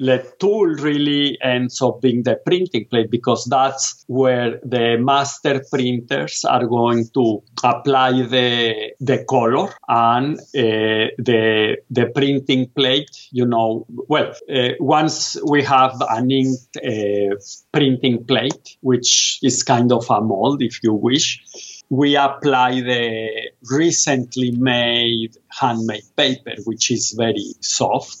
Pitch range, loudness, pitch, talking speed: 115-135 Hz, -18 LUFS, 125 Hz, 130 wpm